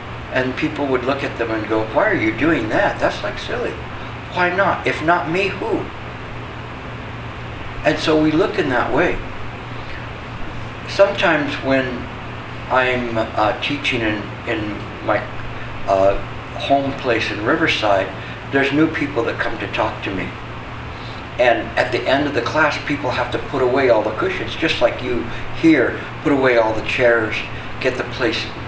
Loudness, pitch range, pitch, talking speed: -19 LUFS, 115-140 Hz, 120 Hz, 165 wpm